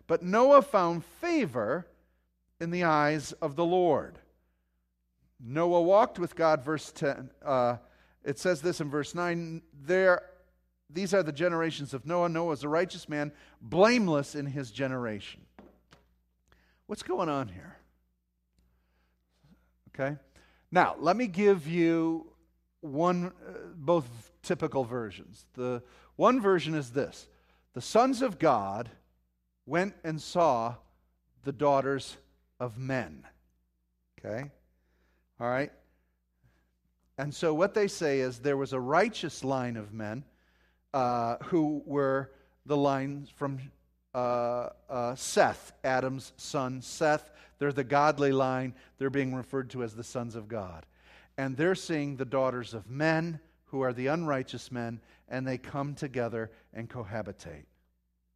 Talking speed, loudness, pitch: 135 wpm, -30 LUFS, 135 Hz